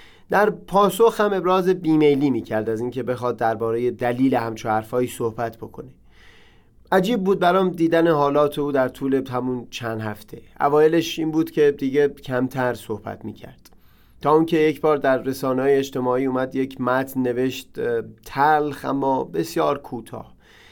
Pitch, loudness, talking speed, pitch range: 135 Hz, -21 LUFS, 150 wpm, 125-155 Hz